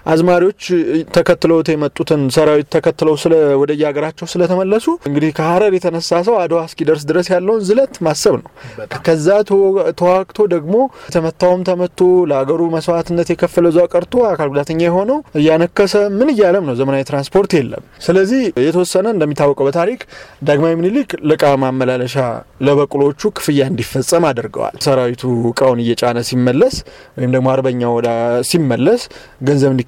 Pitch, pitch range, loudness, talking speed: 165 Hz, 140-180 Hz, -14 LUFS, 120 wpm